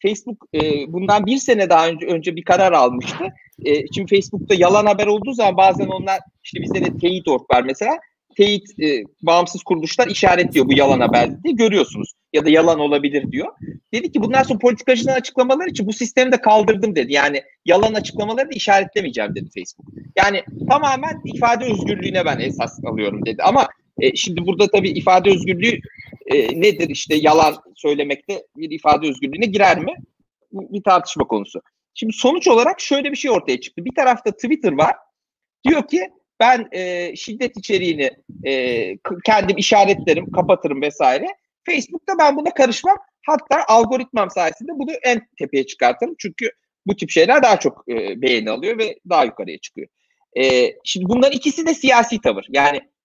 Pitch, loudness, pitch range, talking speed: 210 Hz, -17 LUFS, 180-265 Hz, 160 wpm